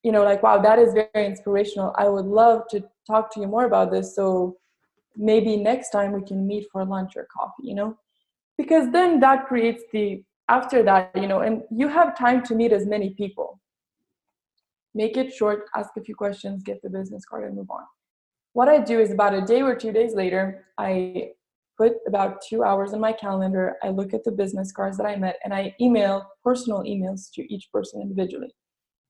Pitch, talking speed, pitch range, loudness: 210 Hz, 205 wpm, 195-230 Hz, -22 LUFS